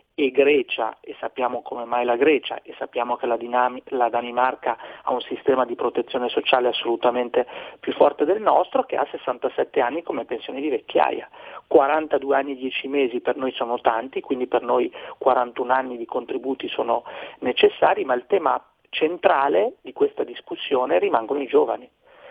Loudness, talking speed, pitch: -22 LUFS, 160 wpm, 135 Hz